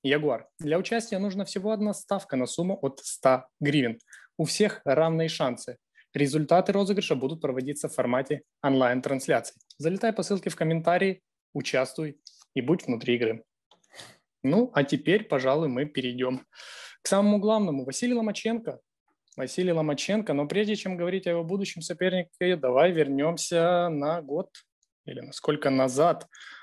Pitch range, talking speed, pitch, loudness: 140-195 Hz, 140 wpm, 165 Hz, -27 LUFS